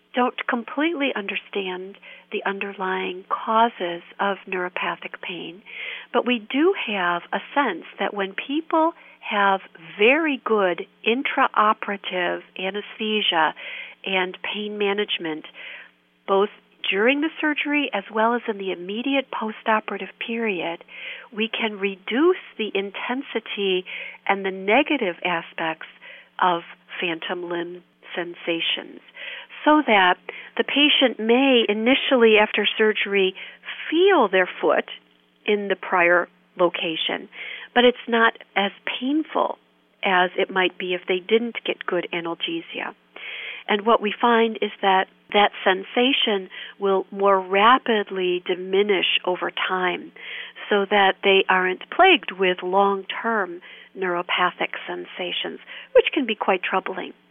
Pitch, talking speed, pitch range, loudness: 200 Hz, 115 wpm, 185-235 Hz, -22 LUFS